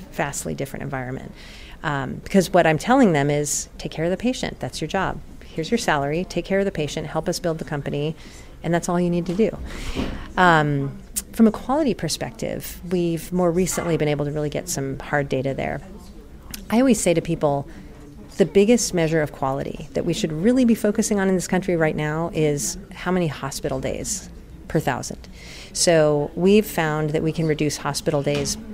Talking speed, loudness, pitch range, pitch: 195 wpm, -22 LUFS, 150-190 Hz, 170 Hz